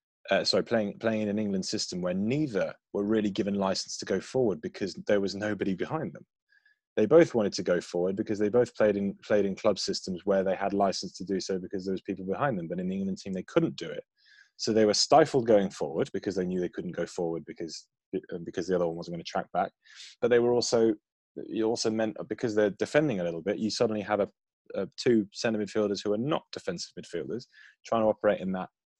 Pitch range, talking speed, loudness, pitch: 95-120 Hz, 235 wpm, -29 LUFS, 105 Hz